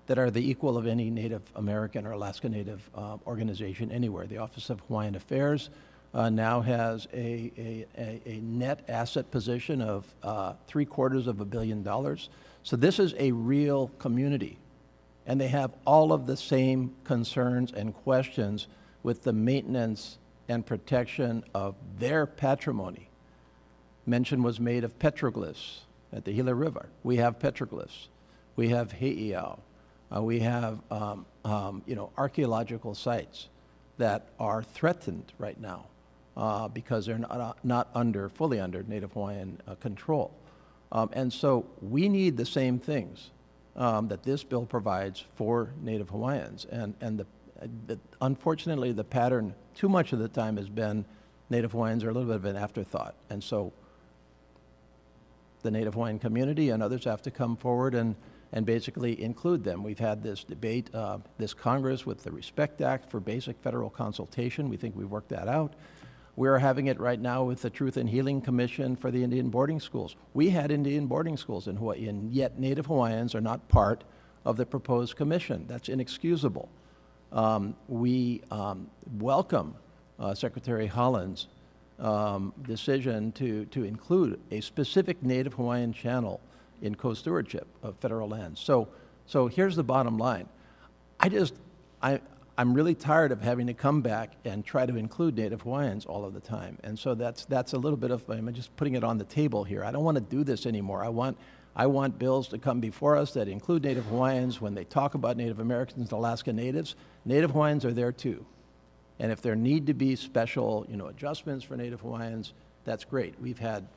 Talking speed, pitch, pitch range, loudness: 180 wpm, 120 Hz, 105-130 Hz, -30 LUFS